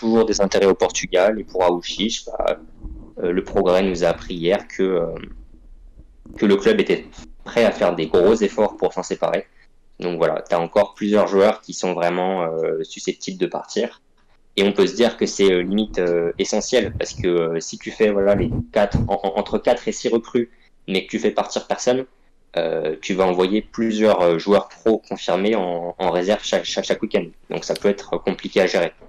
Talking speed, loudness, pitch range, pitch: 205 wpm, -20 LUFS, 85-110 Hz, 100 Hz